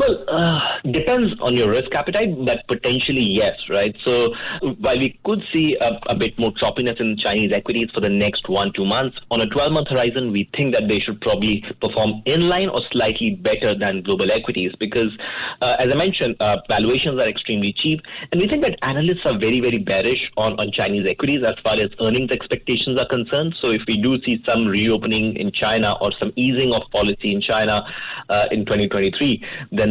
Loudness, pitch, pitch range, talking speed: -19 LUFS, 120 Hz, 105-145 Hz, 200 wpm